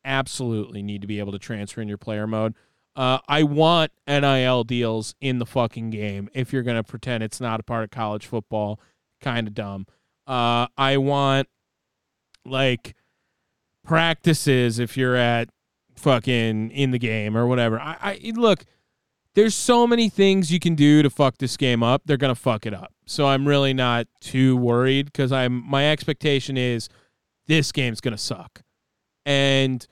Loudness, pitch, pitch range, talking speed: -22 LUFS, 125 Hz, 115-140 Hz, 170 wpm